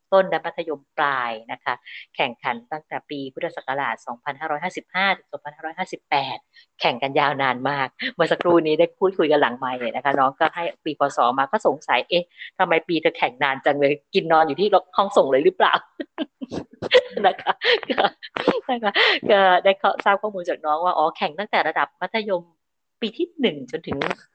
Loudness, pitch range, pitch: -21 LUFS, 155-200 Hz, 175 Hz